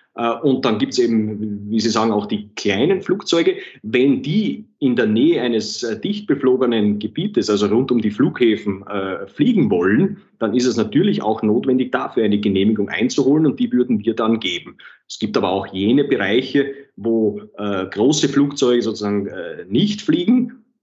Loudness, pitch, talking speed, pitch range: -18 LUFS, 115 Hz, 160 wpm, 105-140 Hz